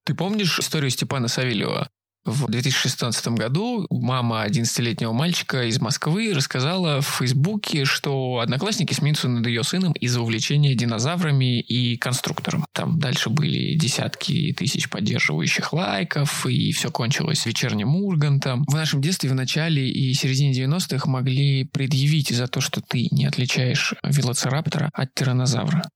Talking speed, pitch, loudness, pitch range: 135 wpm, 140 Hz, -22 LUFS, 130-160 Hz